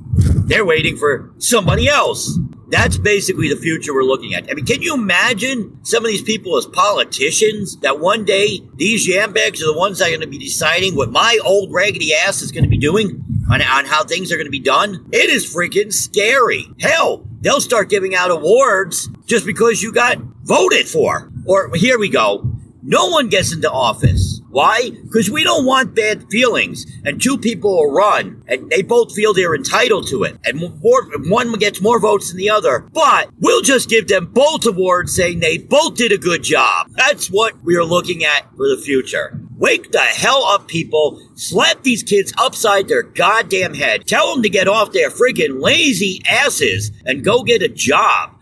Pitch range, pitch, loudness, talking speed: 170-255 Hz, 205 Hz, -14 LUFS, 195 wpm